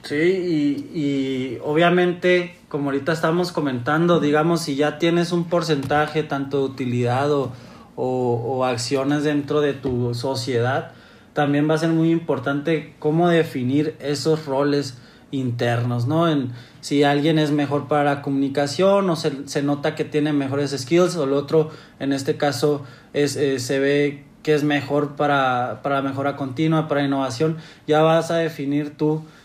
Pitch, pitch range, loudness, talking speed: 145 Hz, 140-155 Hz, -21 LUFS, 155 wpm